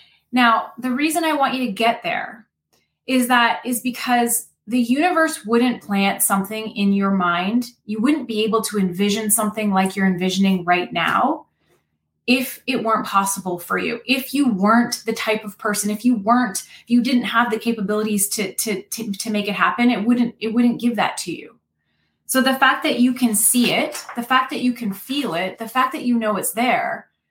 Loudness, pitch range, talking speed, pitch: -19 LUFS, 210-250 Hz, 200 wpm, 235 Hz